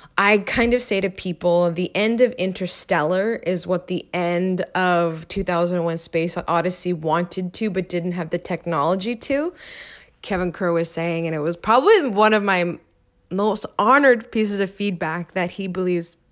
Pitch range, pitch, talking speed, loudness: 175-205 Hz, 180 Hz, 165 wpm, -21 LUFS